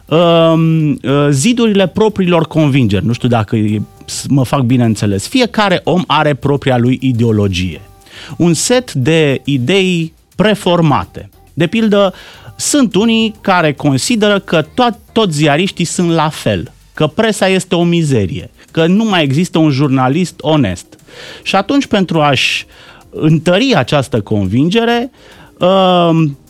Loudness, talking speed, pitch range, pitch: -12 LUFS, 125 wpm, 130-190 Hz, 160 Hz